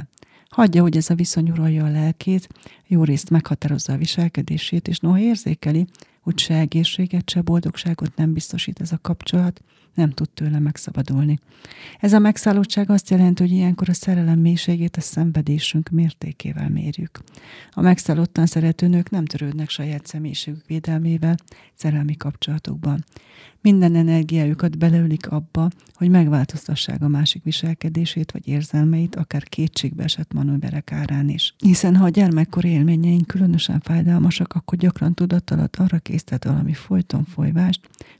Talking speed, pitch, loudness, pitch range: 135 wpm, 165 Hz, -19 LUFS, 155-175 Hz